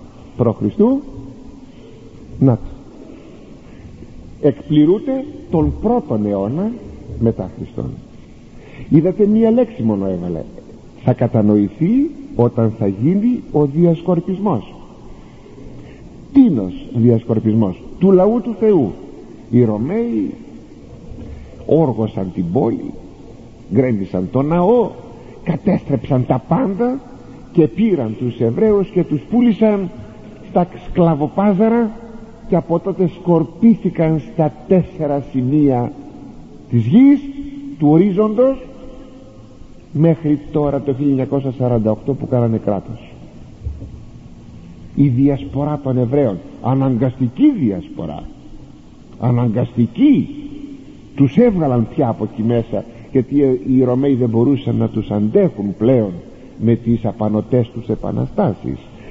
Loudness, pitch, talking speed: -16 LUFS, 140 Hz, 95 wpm